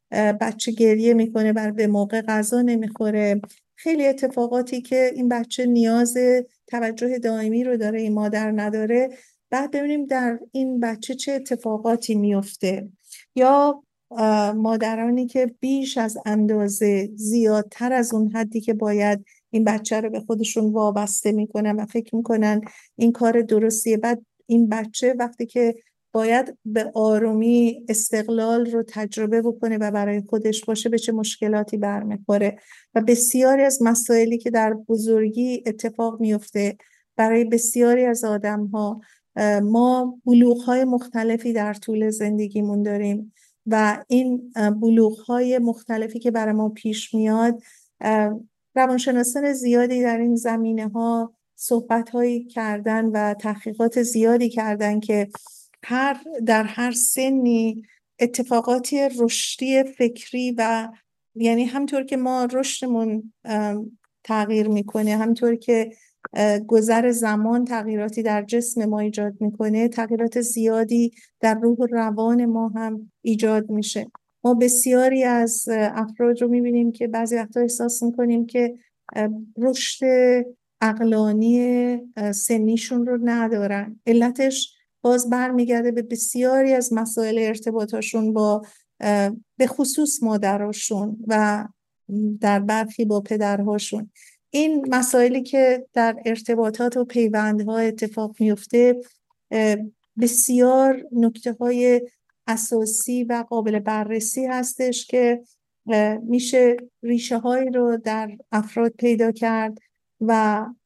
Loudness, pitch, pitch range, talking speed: -21 LUFS, 230 Hz, 215-245 Hz, 115 wpm